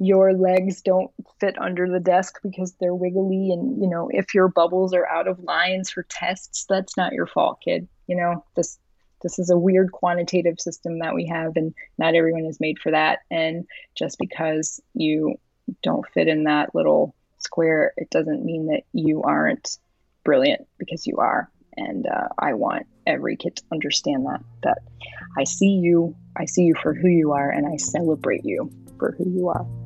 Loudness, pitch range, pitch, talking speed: -22 LUFS, 160-190 Hz, 175 Hz, 190 wpm